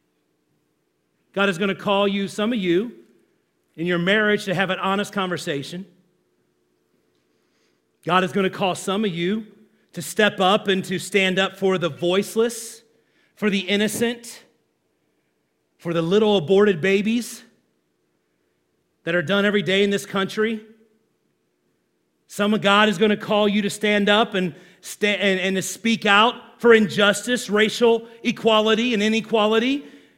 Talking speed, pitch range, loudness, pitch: 150 wpm, 180-215 Hz, -20 LUFS, 200 Hz